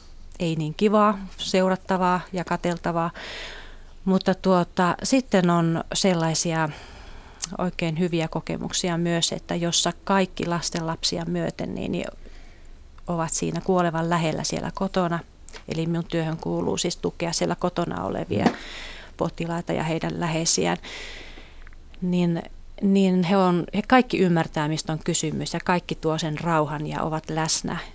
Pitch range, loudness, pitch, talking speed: 160-185 Hz, -24 LUFS, 170 Hz, 125 wpm